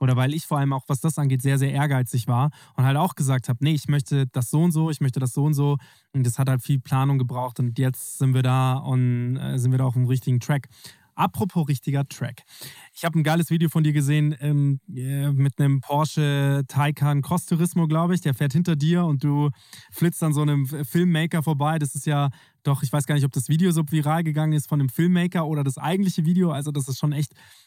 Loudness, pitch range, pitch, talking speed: -23 LUFS, 135-155 Hz, 145 Hz, 235 wpm